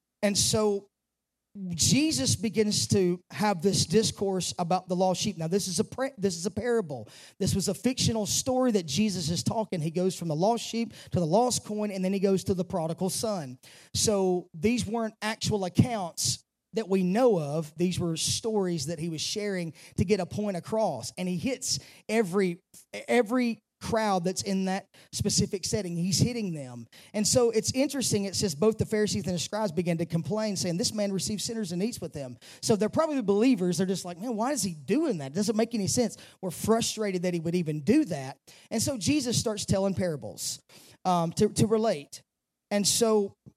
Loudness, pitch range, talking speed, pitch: -28 LUFS, 175-220 Hz, 200 wpm, 200 Hz